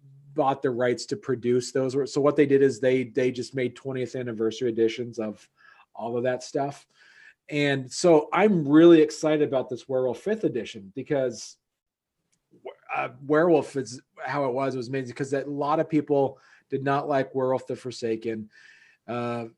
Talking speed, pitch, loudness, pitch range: 170 wpm, 135 Hz, -25 LUFS, 125-145 Hz